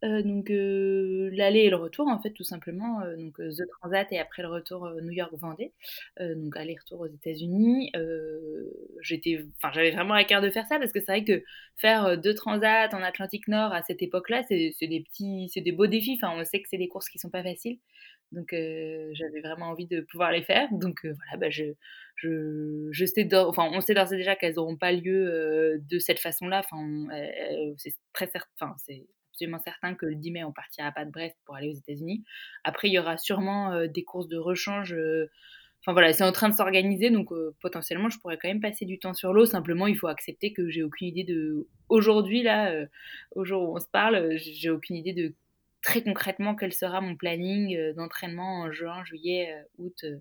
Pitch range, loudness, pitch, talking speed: 165-200 Hz, -28 LUFS, 180 Hz, 230 wpm